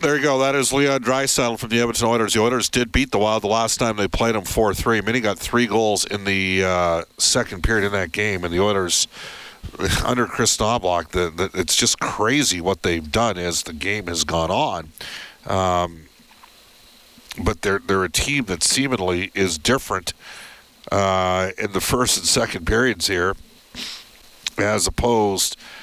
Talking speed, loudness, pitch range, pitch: 180 wpm, -20 LUFS, 95-120 Hz, 100 Hz